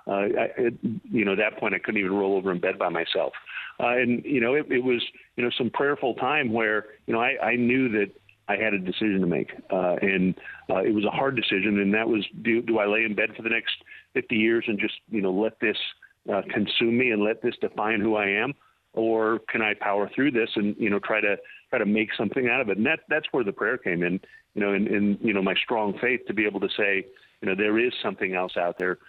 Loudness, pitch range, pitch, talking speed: -25 LUFS, 100-115 Hz, 105 Hz, 265 wpm